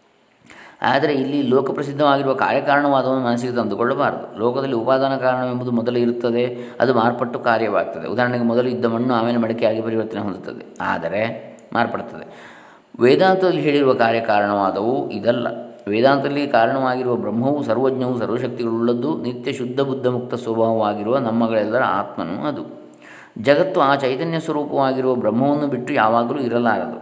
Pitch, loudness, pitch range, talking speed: 125 Hz, -19 LUFS, 115-135 Hz, 105 wpm